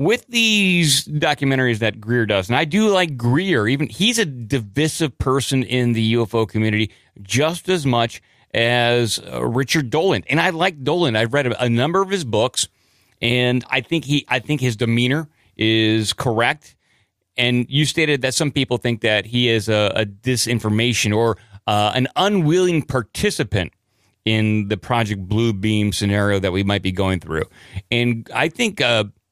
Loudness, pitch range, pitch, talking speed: -19 LUFS, 110-145 Hz, 120 Hz, 170 wpm